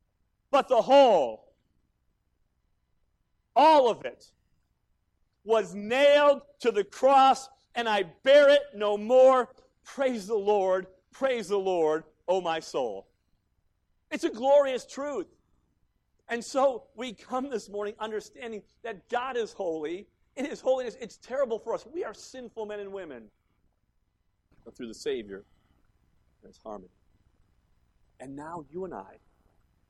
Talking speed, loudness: 130 wpm, -26 LUFS